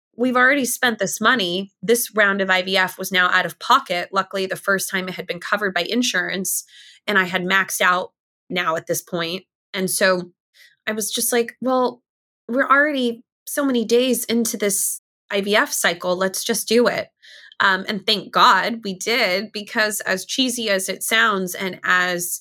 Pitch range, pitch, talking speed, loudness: 185-230 Hz, 195 Hz, 180 wpm, -19 LUFS